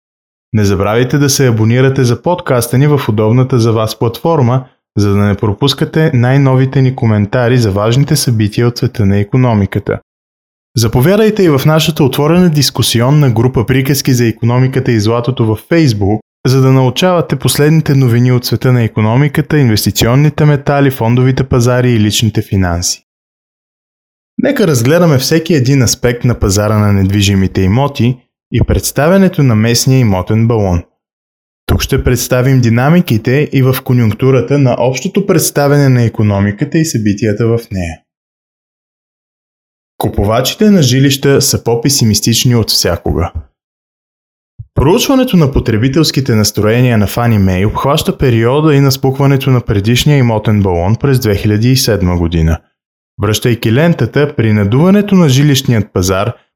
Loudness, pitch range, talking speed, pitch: -10 LUFS, 110-140 Hz, 130 wpm, 125 Hz